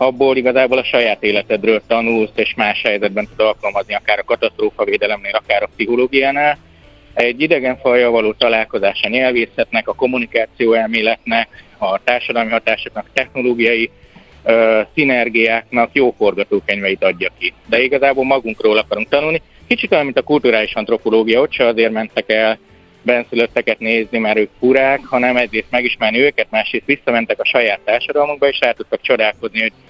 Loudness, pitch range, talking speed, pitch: -15 LUFS, 110-130 Hz, 145 wpm, 115 Hz